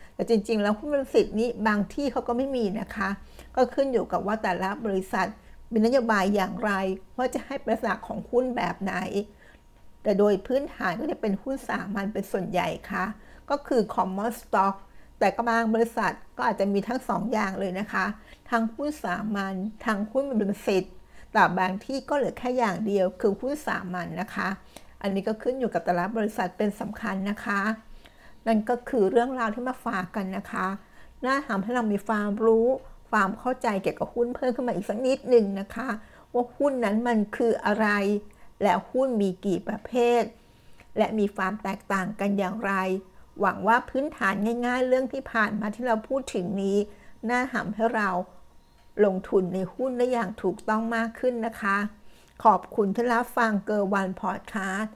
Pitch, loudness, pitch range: 220 Hz, -27 LUFS, 195-240 Hz